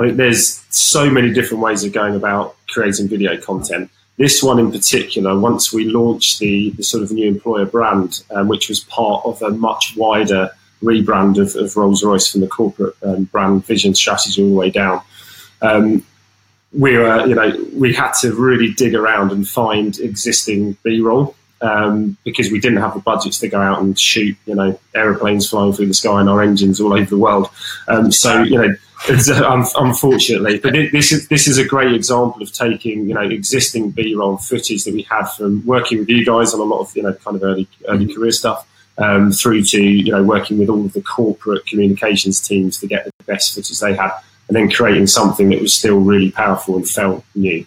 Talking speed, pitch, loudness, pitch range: 210 wpm, 105 Hz, -14 LUFS, 100-115 Hz